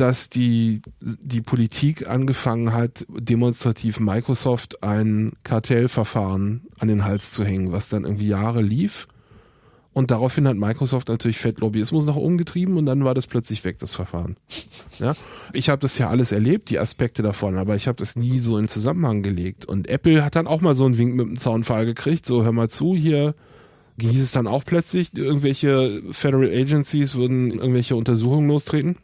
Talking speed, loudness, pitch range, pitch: 180 wpm, -21 LUFS, 110-140 Hz, 125 Hz